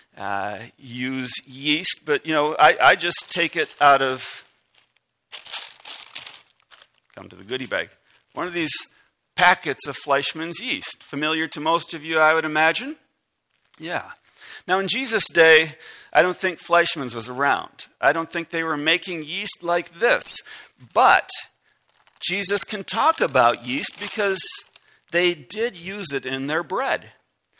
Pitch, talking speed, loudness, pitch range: 165 Hz, 145 wpm, -20 LUFS, 145-185 Hz